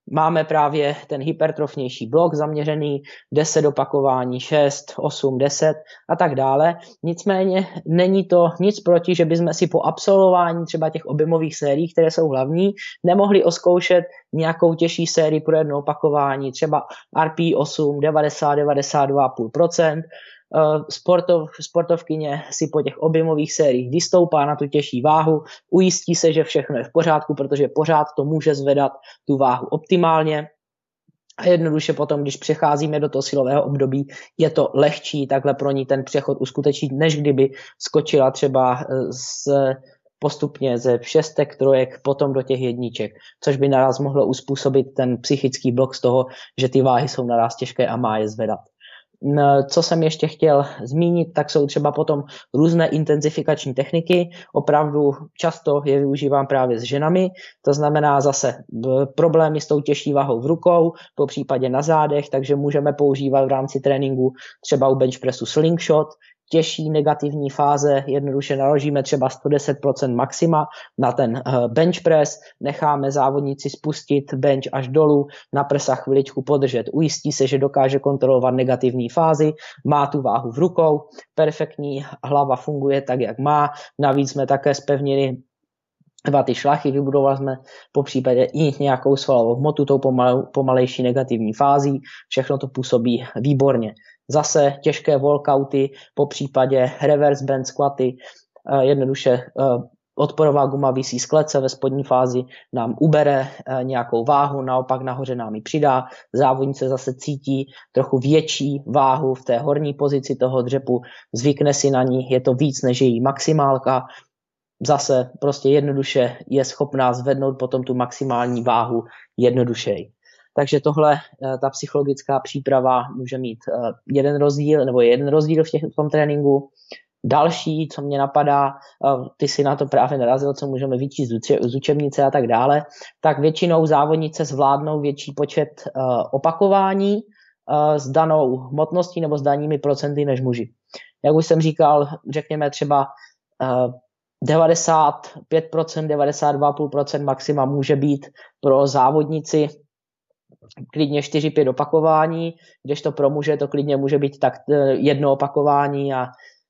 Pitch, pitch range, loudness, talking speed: 145 Hz, 135-155 Hz, -19 LUFS, 140 wpm